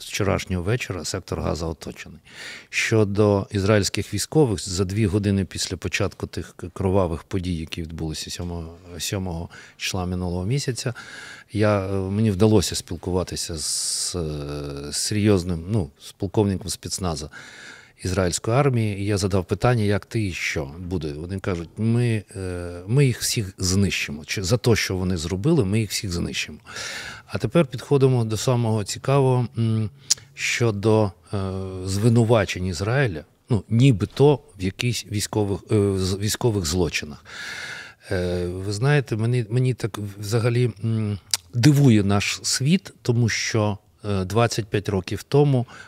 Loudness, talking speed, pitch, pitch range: -23 LUFS, 120 wpm, 105 Hz, 95-115 Hz